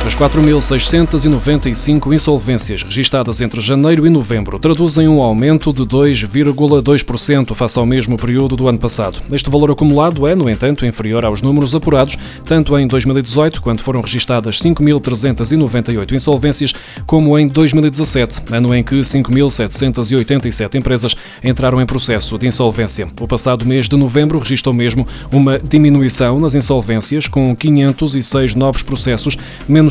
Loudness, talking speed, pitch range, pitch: -12 LUFS, 135 wpm, 120-145 Hz, 135 Hz